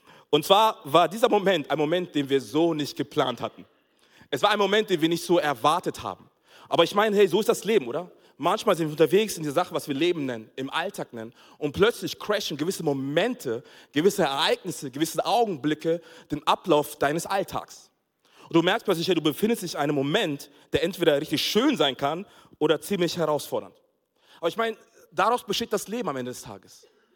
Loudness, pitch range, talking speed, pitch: -25 LUFS, 145-195 Hz, 200 wpm, 165 Hz